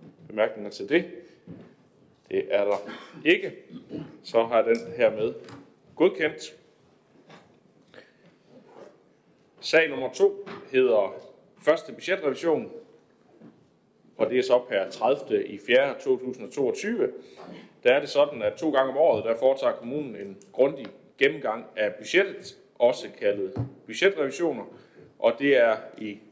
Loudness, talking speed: -25 LUFS, 120 wpm